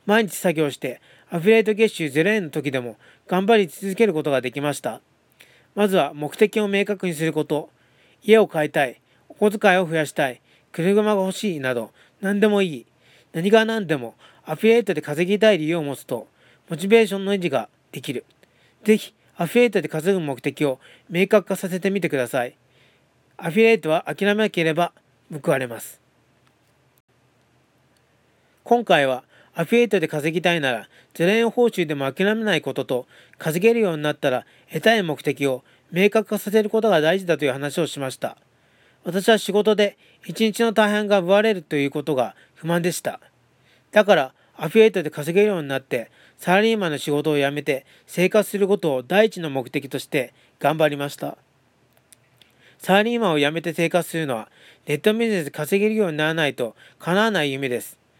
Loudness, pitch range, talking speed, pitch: -21 LUFS, 150-210 Hz, 355 characters per minute, 175 Hz